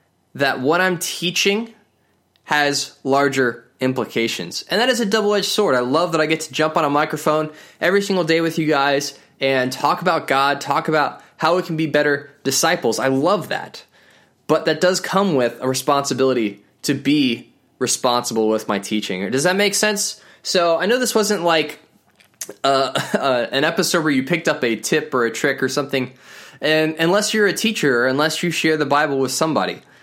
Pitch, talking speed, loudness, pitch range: 155 Hz, 190 wpm, -19 LUFS, 135-180 Hz